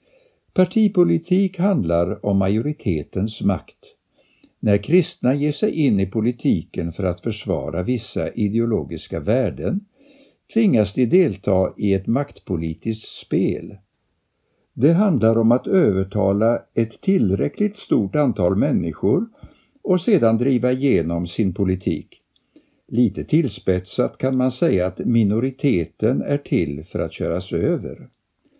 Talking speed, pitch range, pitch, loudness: 115 wpm, 95-155 Hz, 115 Hz, -20 LUFS